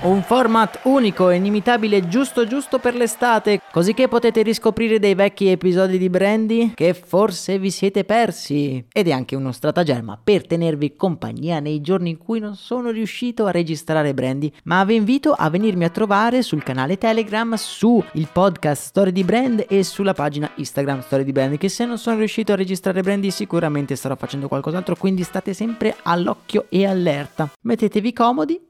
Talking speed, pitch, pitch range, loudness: 175 wpm, 195 Hz, 160-225 Hz, -19 LUFS